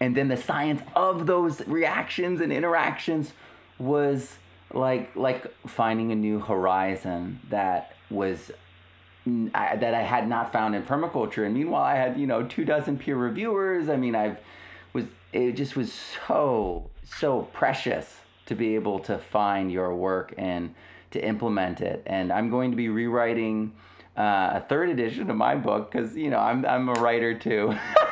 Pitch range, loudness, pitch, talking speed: 95-140 Hz, -26 LUFS, 115 Hz, 165 wpm